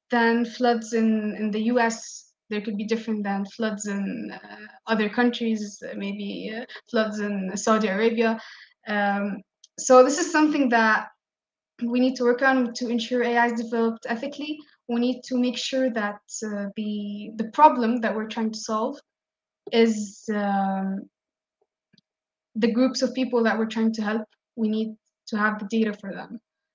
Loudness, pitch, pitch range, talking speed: -24 LUFS, 225 Hz, 215-245 Hz, 165 wpm